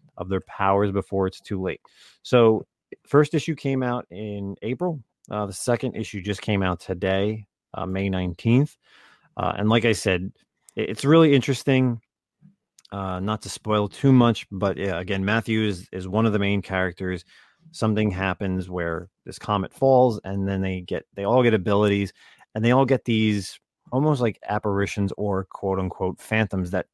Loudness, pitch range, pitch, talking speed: -23 LUFS, 95-120 Hz, 105 Hz, 170 wpm